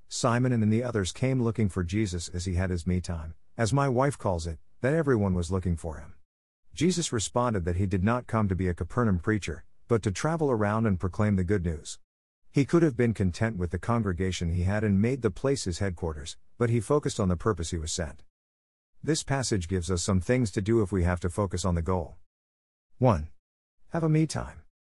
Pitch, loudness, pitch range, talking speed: 95 Hz, -28 LUFS, 85-115 Hz, 225 wpm